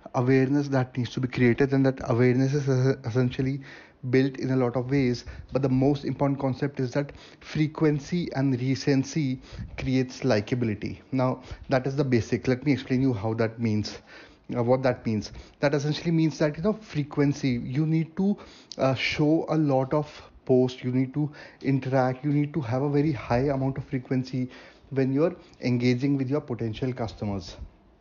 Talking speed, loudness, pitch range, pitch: 180 wpm, -26 LUFS, 125-145 Hz, 135 Hz